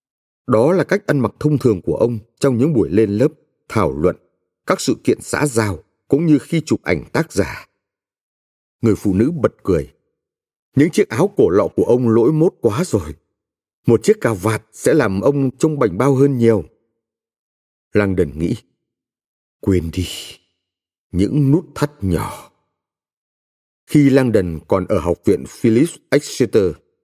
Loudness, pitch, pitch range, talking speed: -17 LUFS, 115 Hz, 90-140 Hz, 165 wpm